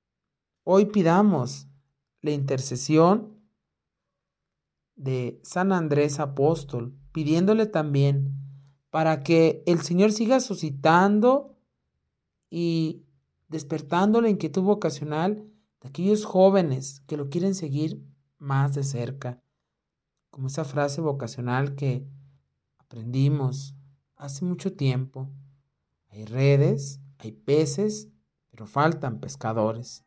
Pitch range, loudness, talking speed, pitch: 135-170 Hz, -24 LUFS, 95 wpm, 145 Hz